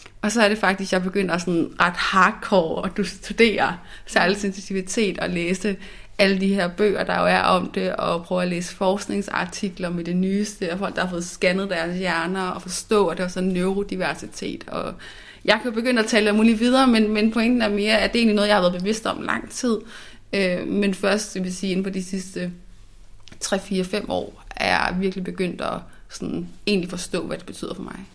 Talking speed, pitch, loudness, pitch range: 220 wpm, 195 Hz, -22 LUFS, 180-210 Hz